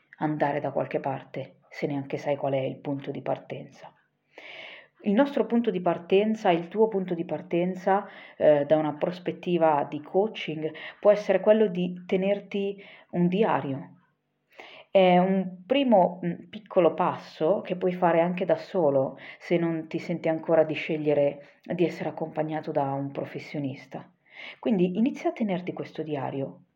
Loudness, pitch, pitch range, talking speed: -26 LUFS, 170 Hz, 155-195 Hz, 150 wpm